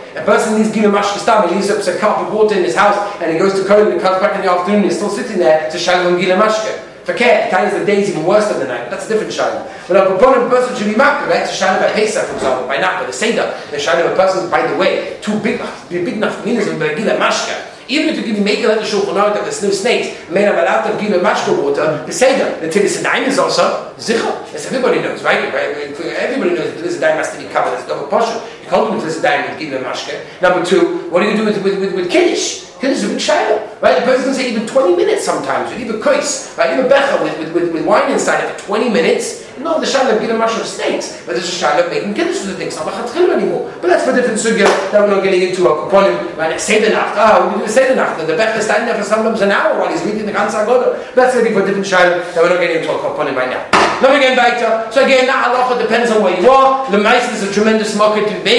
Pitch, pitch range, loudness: 215 Hz, 195-260 Hz, -14 LUFS